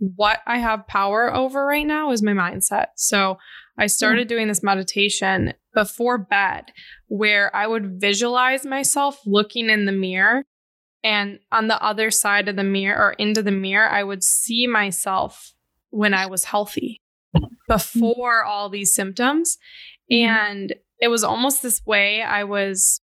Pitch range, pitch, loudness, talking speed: 200-235 Hz, 210 Hz, -19 LUFS, 155 wpm